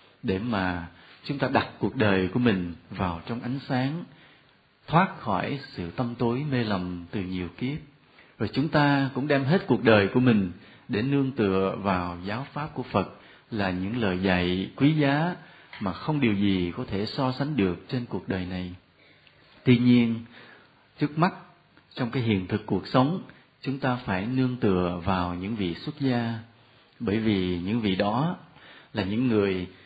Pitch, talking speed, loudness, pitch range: 115 Hz, 175 wpm, -26 LUFS, 95-135 Hz